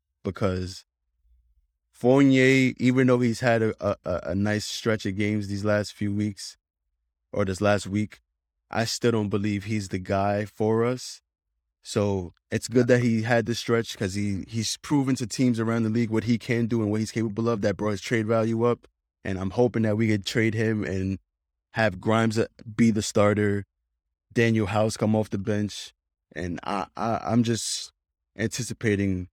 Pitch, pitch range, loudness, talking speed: 105 Hz, 95-115 Hz, -25 LUFS, 180 wpm